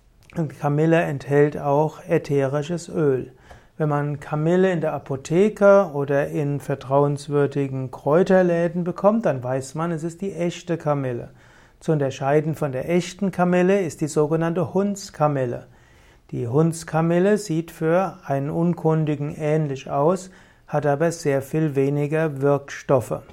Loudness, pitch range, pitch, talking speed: -22 LUFS, 145-170 Hz, 155 Hz, 125 wpm